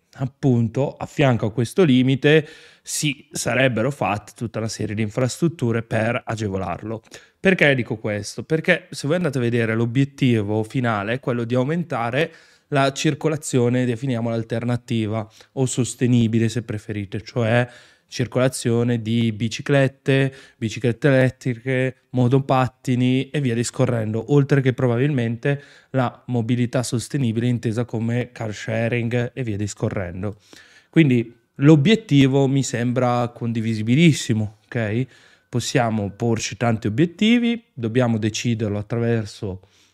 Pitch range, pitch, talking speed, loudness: 115-135 Hz, 120 Hz, 115 wpm, -21 LUFS